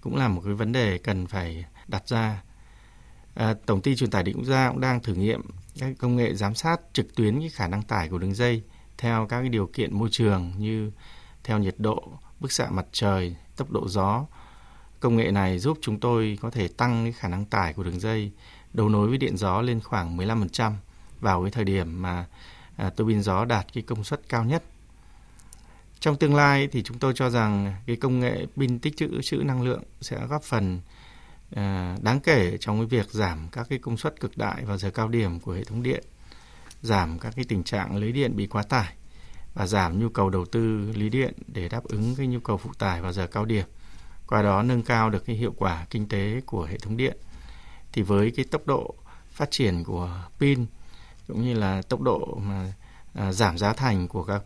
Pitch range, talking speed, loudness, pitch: 95-120 Hz, 215 wpm, -26 LUFS, 110 Hz